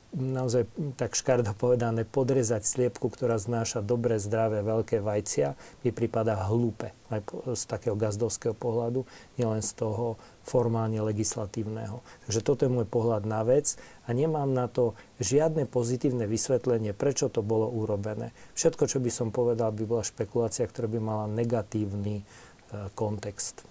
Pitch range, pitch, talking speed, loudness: 110-125 Hz, 115 Hz, 140 wpm, -29 LUFS